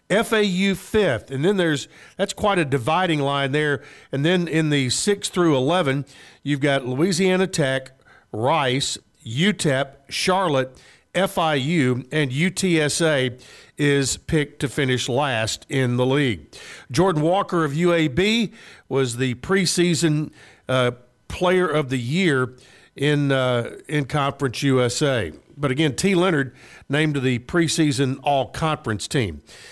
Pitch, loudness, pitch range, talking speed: 145 Hz, -21 LUFS, 130-175 Hz, 130 wpm